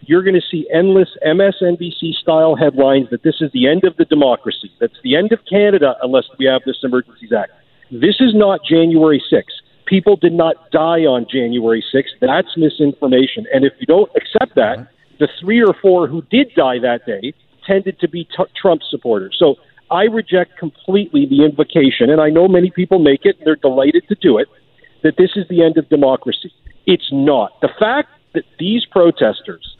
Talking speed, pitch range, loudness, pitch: 190 wpm, 150-195 Hz, -14 LUFS, 165 Hz